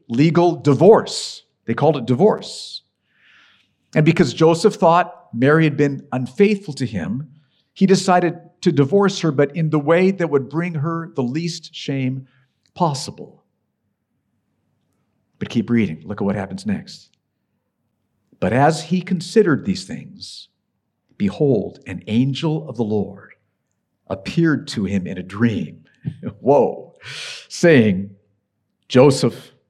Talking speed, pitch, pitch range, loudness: 125 wpm, 155 Hz, 130-175 Hz, -18 LUFS